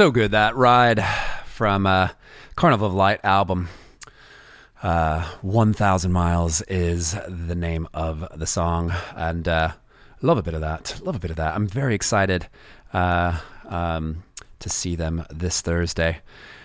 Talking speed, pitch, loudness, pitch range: 150 wpm, 90 Hz, -22 LUFS, 85-100 Hz